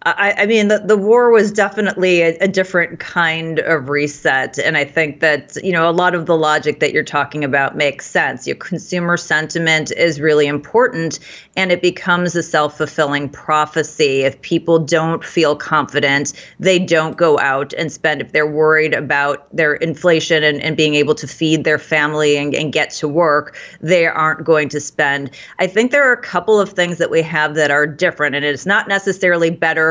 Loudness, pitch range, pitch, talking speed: -15 LUFS, 150-175 Hz, 160 Hz, 195 wpm